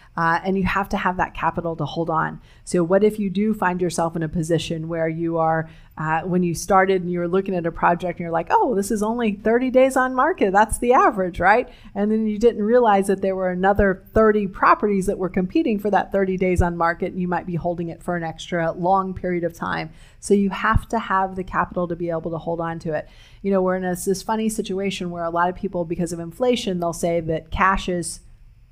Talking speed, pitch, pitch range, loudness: 245 wpm, 180 Hz, 170-200 Hz, -21 LUFS